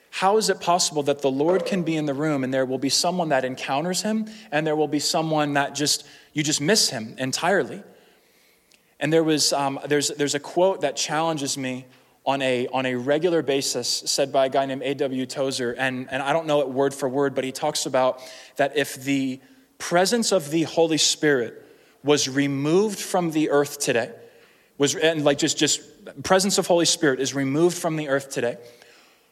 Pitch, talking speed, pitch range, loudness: 145 Hz, 200 wpm, 135-160 Hz, -23 LUFS